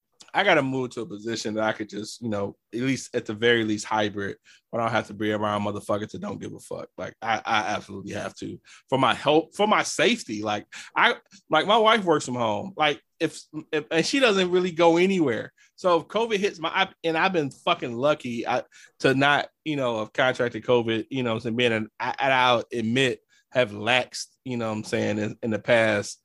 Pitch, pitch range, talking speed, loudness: 125 Hz, 110-155 Hz, 230 wpm, -24 LUFS